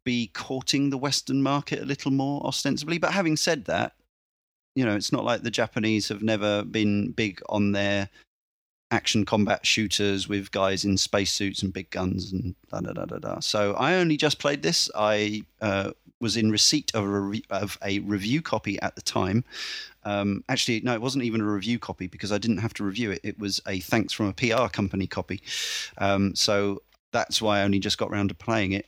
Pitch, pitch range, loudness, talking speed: 105 Hz, 100-120 Hz, -26 LUFS, 210 wpm